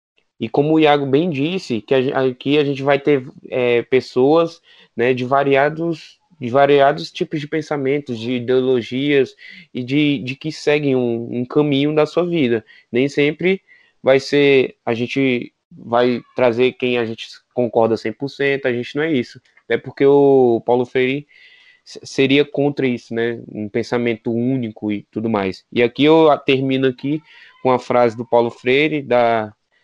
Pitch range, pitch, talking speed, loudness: 120-145 Hz, 130 Hz, 165 wpm, -18 LUFS